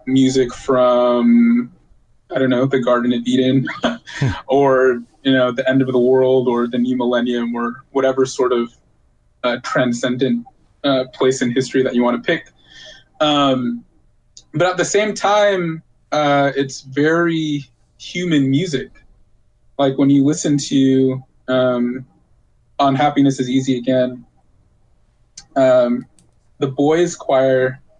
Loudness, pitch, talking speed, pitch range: -17 LUFS, 130 Hz, 130 wpm, 125-140 Hz